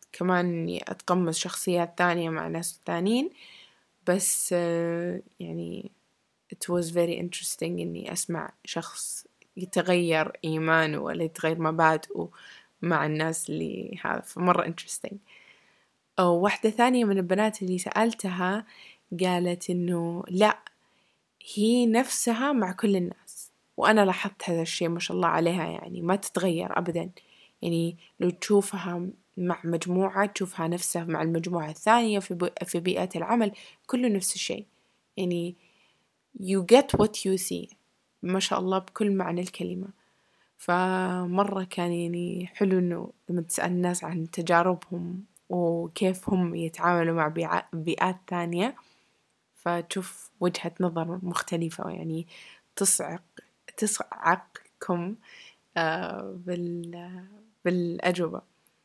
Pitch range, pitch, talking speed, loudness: 170-195 Hz, 180 Hz, 110 wpm, -27 LUFS